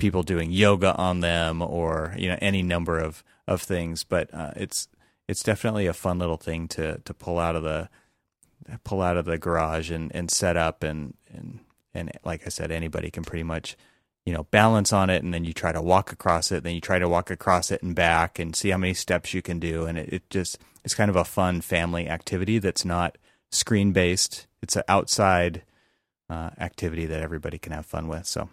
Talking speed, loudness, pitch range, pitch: 220 wpm, -25 LUFS, 80-95 Hz, 85 Hz